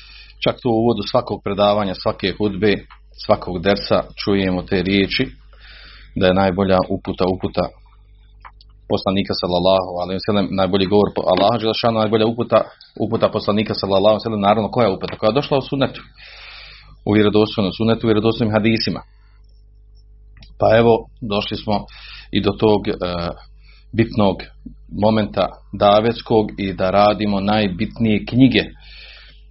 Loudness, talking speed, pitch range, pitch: -18 LUFS, 130 wpm, 100-110 Hz, 105 Hz